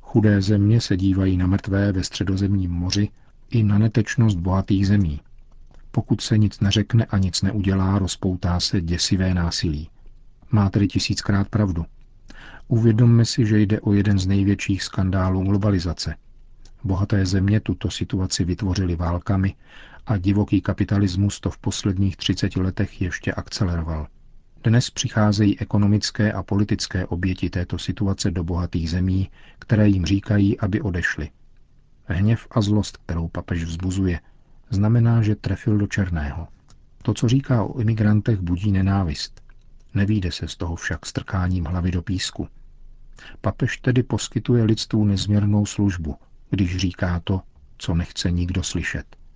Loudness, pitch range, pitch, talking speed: -22 LUFS, 90-105 Hz, 100 Hz, 135 wpm